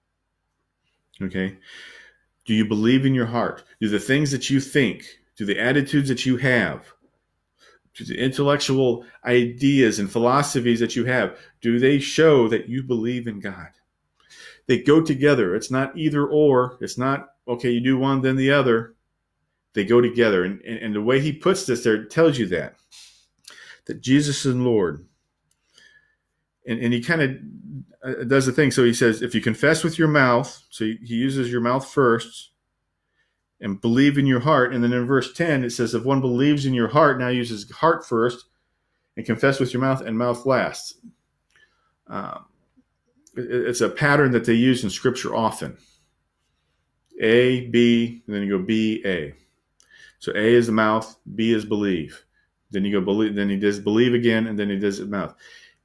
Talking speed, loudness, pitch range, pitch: 180 wpm, -21 LUFS, 110-135 Hz, 120 Hz